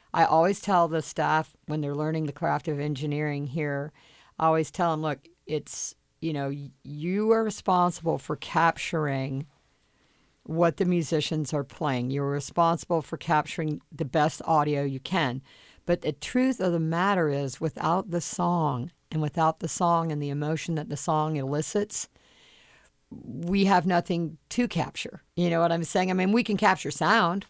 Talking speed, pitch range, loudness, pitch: 170 wpm, 150-175 Hz, -27 LUFS, 160 Hz